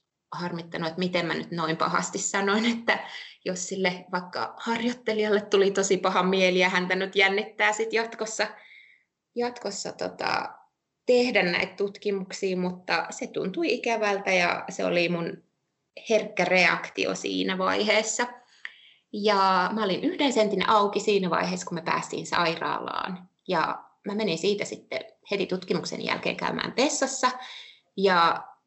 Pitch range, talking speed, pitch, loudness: 180-215 Hz, 130 wpm, 200 Hz, -26 LUFS